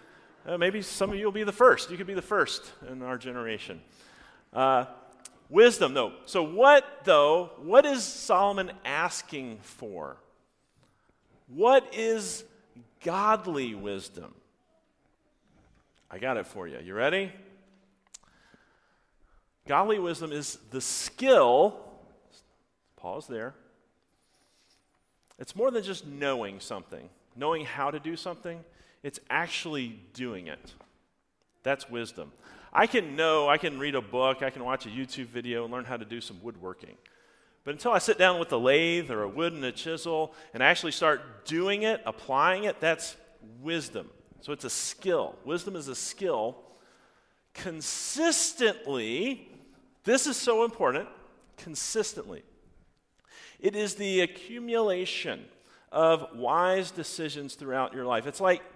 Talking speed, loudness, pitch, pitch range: 135 wpm, -27 LUFS, 165 Hz, 130-205 Hz